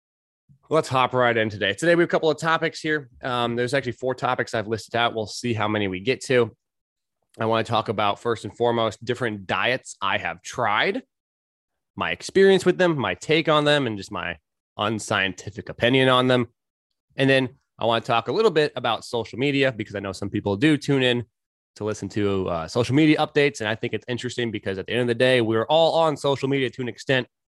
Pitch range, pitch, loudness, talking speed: 105-135 Hz, 120 Hz, -23 LUFS, 225 wpm